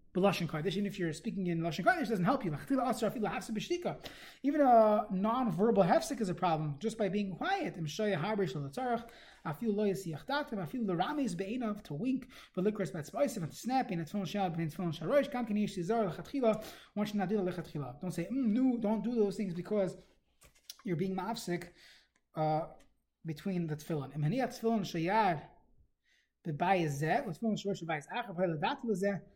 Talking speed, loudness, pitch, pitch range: 210 wpm, -34 LUFS, 200 Hz, 175-230 Hz